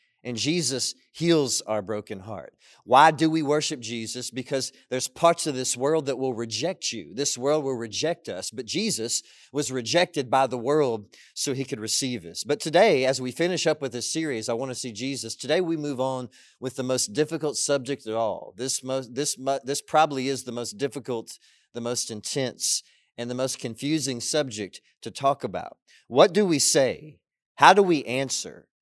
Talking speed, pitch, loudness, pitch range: 190 wpm, 130 Hz, -25 LUFS, 120-145 Hz